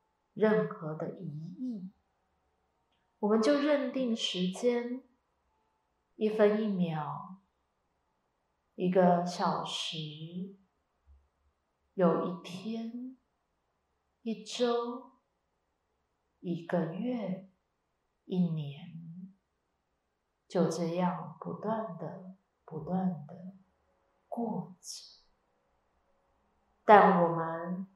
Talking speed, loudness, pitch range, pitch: 95 characters per minute, -31 LUFS, 160-215 Hz, 180 Hz